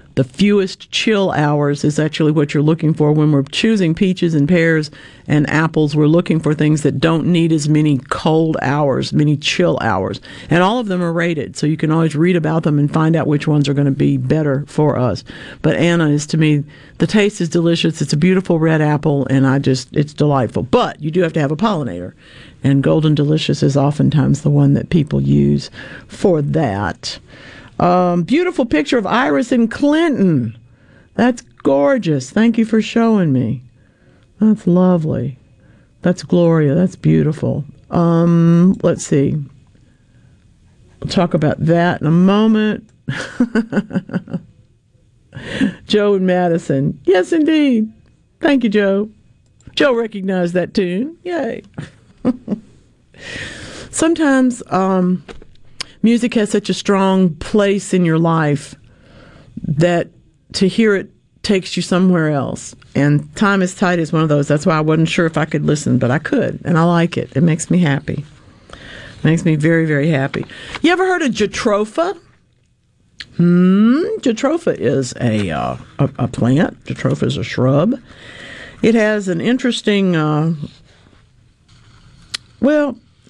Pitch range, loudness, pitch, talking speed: 140-195 Hz, -15 LUFS, 160 Hz, 155 wpm